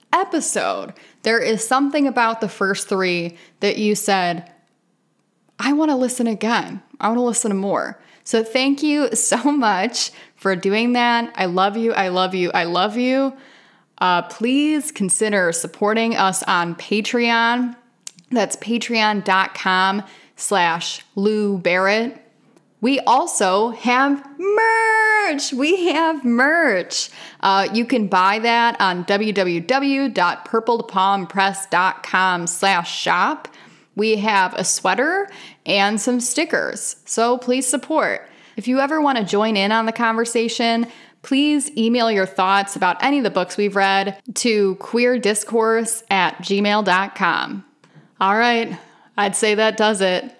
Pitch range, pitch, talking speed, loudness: 195-250 Hz, 225 Hz, 130 wpm, -18 LUFS